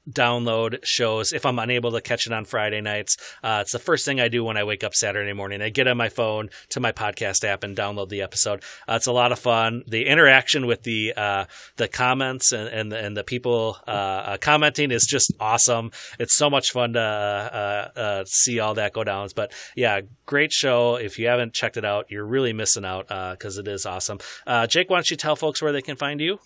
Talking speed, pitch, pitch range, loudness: 235 wpm, 115 Hz, 105-125 Hz, -22 LUFS